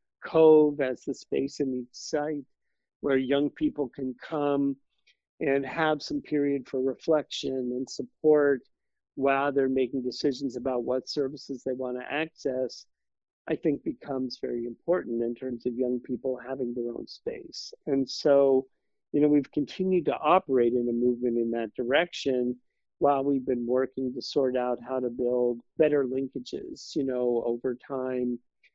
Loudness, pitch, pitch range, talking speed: -28 LUFS, 130 Hz, 125-145 Hz, 155 wpm